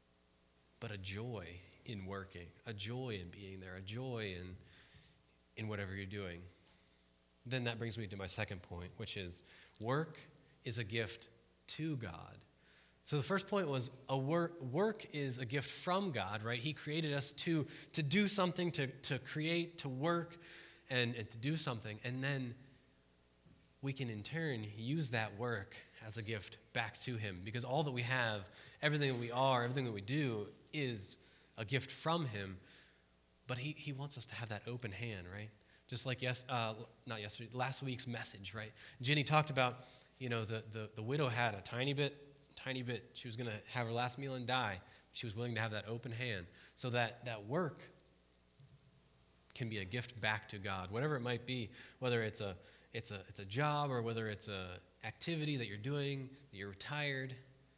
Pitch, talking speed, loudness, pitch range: 120 Hz, 190 wpm, -39 LUFS, 105-135 Hz